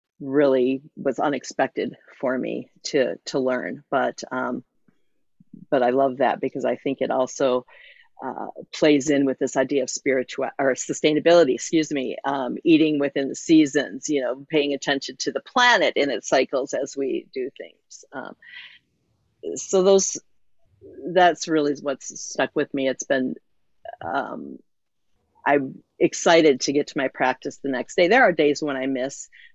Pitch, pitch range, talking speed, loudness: 145 Hz, 135-170 Hz, 160 wpm, -22 LUFS